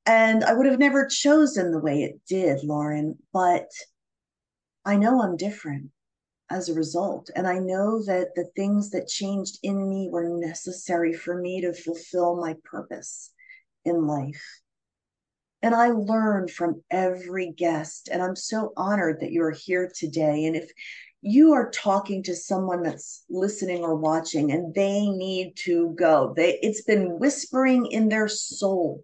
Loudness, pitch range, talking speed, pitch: -24 LUFS, 165-205 Hz, 160 wpm, 180 Hz